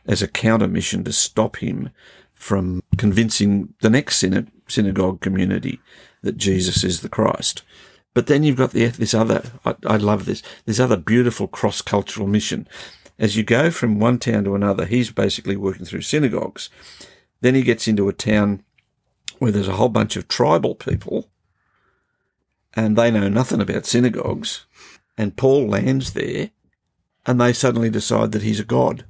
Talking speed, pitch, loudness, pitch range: 165 wpm, 110 Hz, -19 LUFS, 100-120 Hz